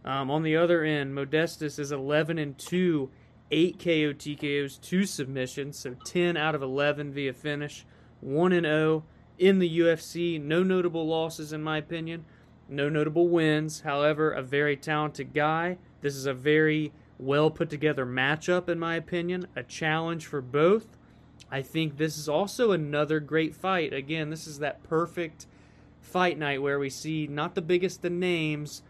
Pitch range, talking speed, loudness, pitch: 145-170 Hz, 165 wpm, -28 LUFS, 155 Hz